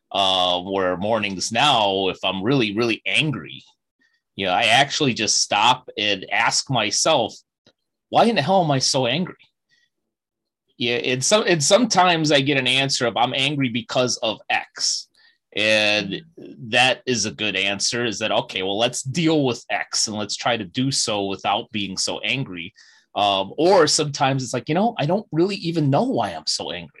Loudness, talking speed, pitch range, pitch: -20 LUFS, 180 wpm, 105-150 Hz, 125 Hz